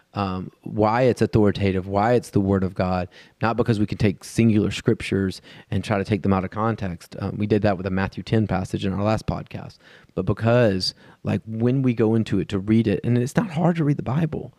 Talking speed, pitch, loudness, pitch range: 235 wpm, 105 Hz, -22 LUFS, 100-115 Hz